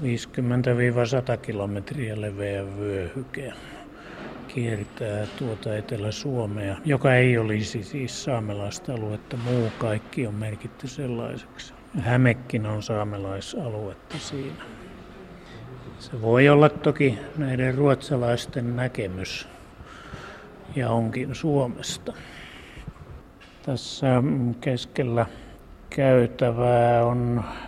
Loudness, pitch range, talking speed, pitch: -25 LUFS, 110-130 Hz, 80 wpm, 120 Hz